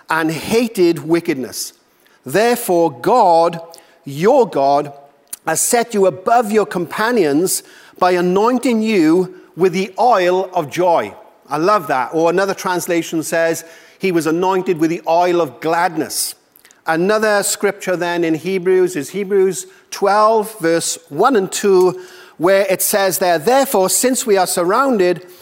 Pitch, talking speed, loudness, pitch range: 180 Hz, 135 wpm, -15 LUFS, 165-200 Hz